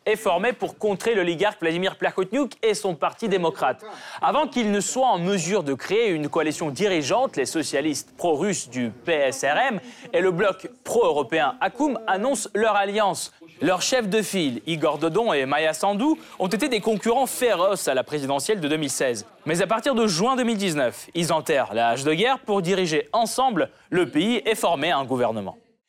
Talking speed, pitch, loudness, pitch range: 175 wpm, 200 Hz, -23 LUFS, 160-230 Hz